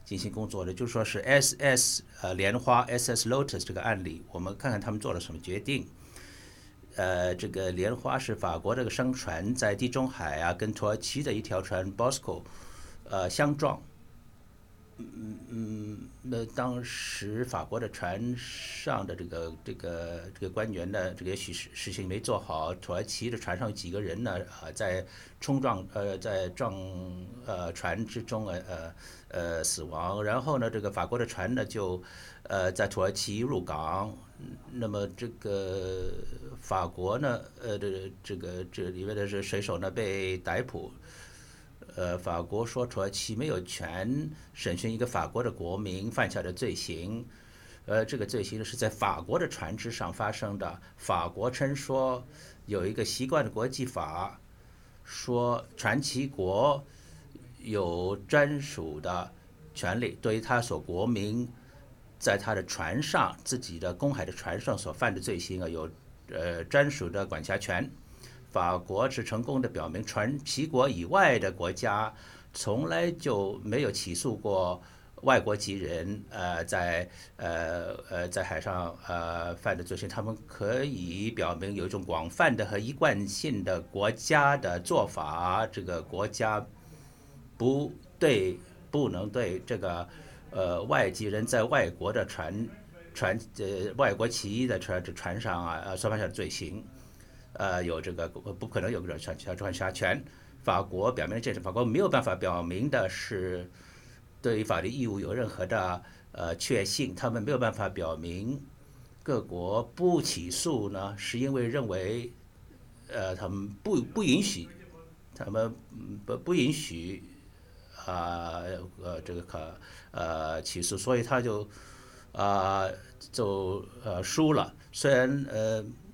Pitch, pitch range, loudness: 100 Hz, 90-120 Hz, -32 LUFS